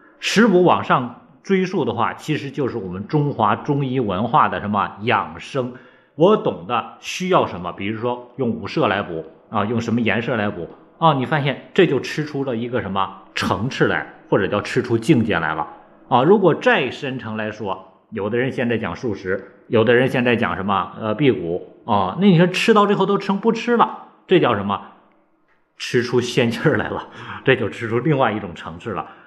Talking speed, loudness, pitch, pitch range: 280 characters per minute, -19 LUFS, 120 Hz, 105-145 Hz